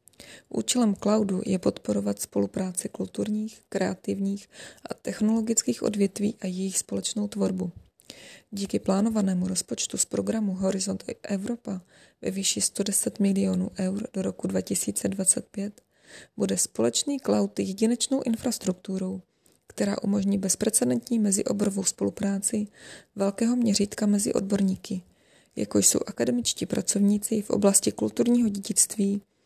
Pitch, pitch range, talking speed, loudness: 200 Hz, 185-215 Hz, 105 wpm, -26 LUFS